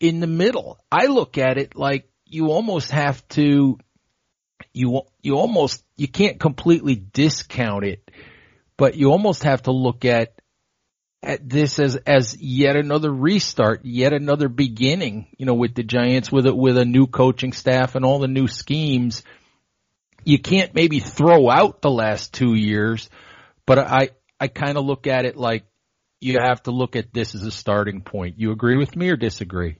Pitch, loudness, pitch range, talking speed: 130 Hz, -19 LUFS, 120-145 Hz, 175 wpm